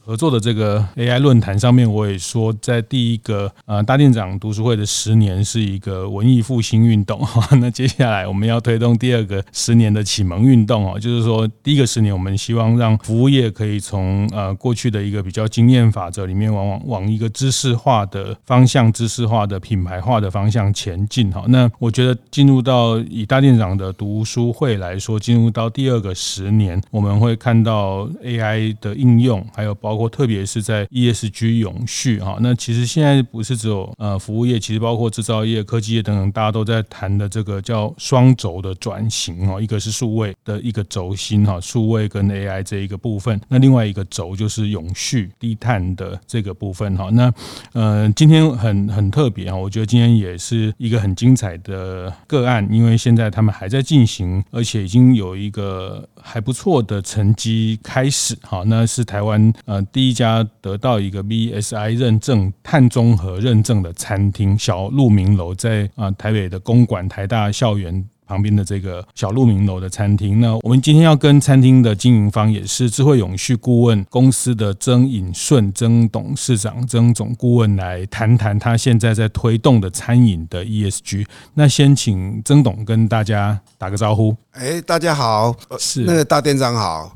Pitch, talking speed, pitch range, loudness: 110 Hz, 290 characters per minute, 100-120 Hz, -16 LUFS